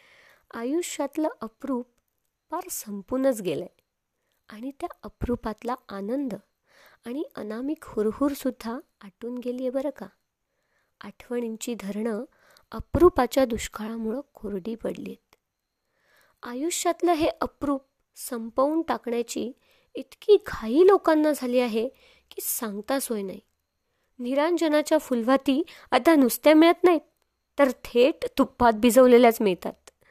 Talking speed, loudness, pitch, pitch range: 100 wpm, -25 LUFS, 260 Hz, 230-310 Hz